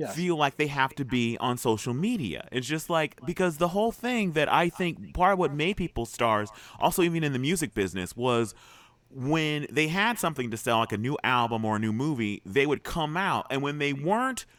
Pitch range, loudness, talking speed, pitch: 120-175 Hz, -27 LUFS, 220 wpm, 145 Hz